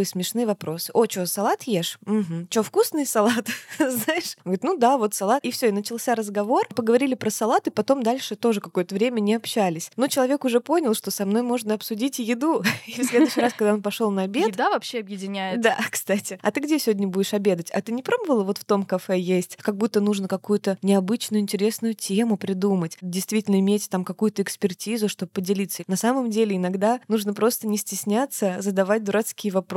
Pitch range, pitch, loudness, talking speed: 195-235 Hz, 210 Hz, -23 LUFS, 200 wpm